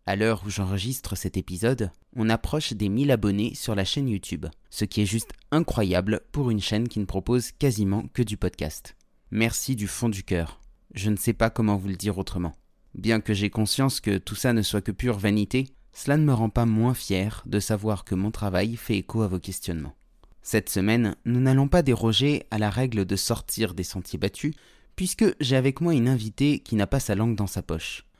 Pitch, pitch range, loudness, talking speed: 110 Hz, 100-120 Hz, -26 LUFS, 215 wpm